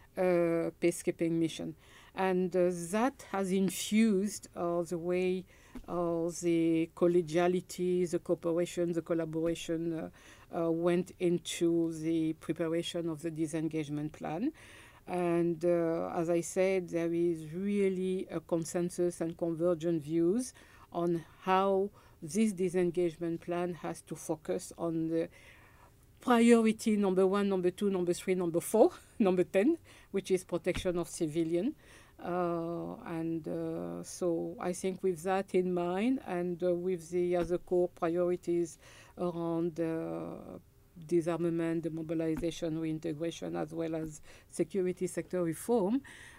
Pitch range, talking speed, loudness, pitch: 165-180 Hz, 130 wpm, -33 LUFS, 175 Hz